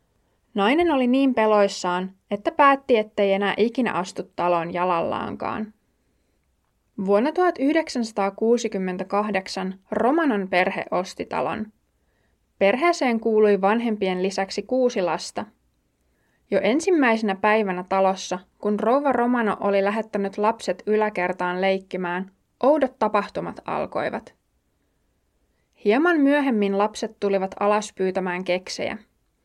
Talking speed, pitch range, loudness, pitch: 95 wpm, 190-235 Hz, -22 LUFS, 205 Hz